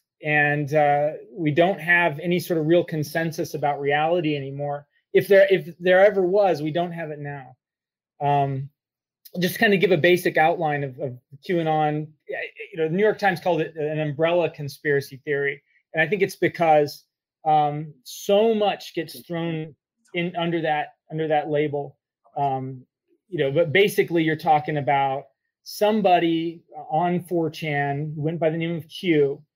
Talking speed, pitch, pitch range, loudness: 160 wpm, 160 Hz, 145-175 Hz, -22 LUFS